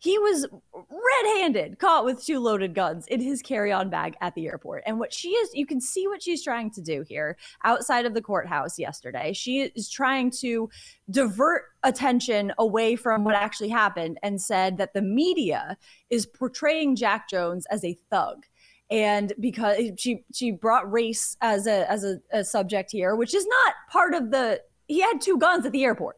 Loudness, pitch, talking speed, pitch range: -25 LUFS, 230 Hz, 190 wpm, 205-275 Hz